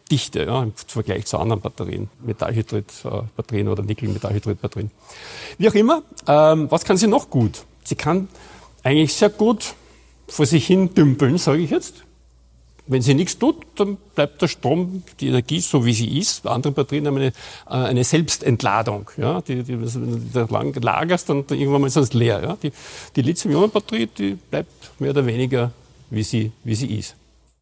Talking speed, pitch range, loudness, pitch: 175 wpm, 110-155 Hz, -20 LUFS, 130 Hz